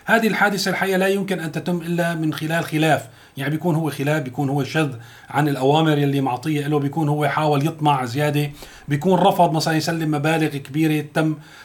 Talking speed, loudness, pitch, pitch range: 180 wpm, -20 LUFS, 155 Hz, 145-165 Hz